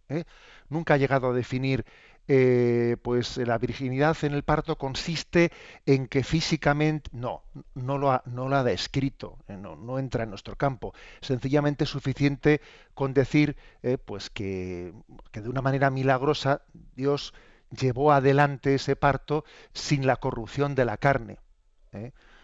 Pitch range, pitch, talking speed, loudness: 125-145 Hz, 135 Hz, 150 wpm, -26 LUFS